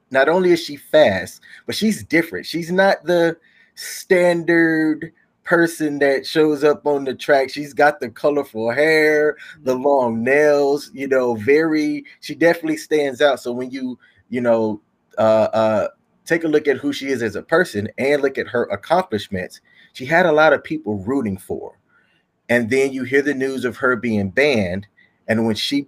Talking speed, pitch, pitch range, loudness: 180 wpm, 145 Hz, 125-160 Hz, -18 LUFS